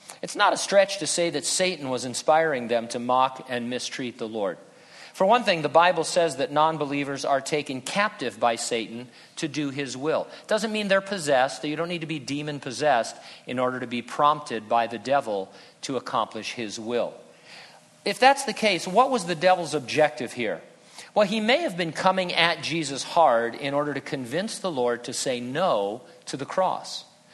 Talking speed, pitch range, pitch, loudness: 200 wpm, 125-180 Hz, 150 Hz, -25 LUFS